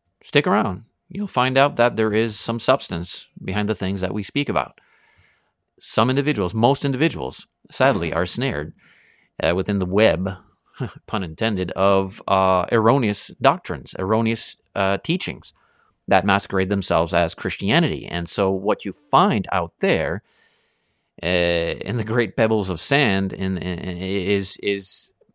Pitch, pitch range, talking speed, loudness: 100 Hz, 95-115 Hz, 140 wpm, -21 LUFS